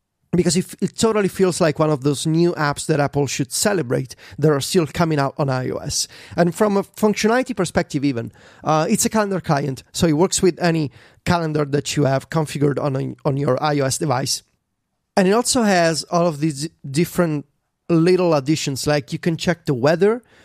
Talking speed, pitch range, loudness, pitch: 190 wpm, 145-180 Hz, -19 LUFS, 160 Hz